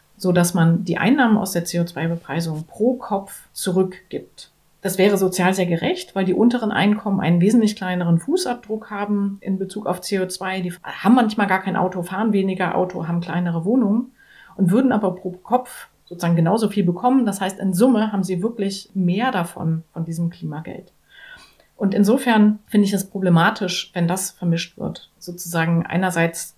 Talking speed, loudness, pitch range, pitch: 165 wpm, -20 LUFS, 175-210 Hz, 190 Hz